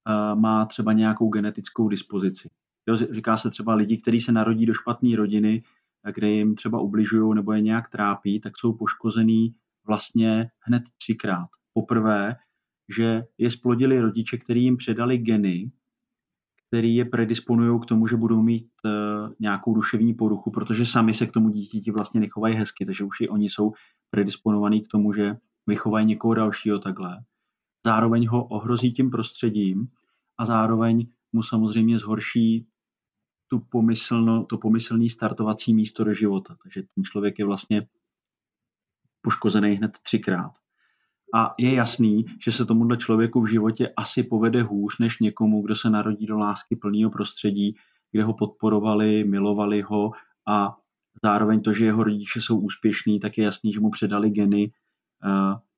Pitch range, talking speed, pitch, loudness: 105-115 Hz, 150 wpm, 110 Hz, -23 LUFS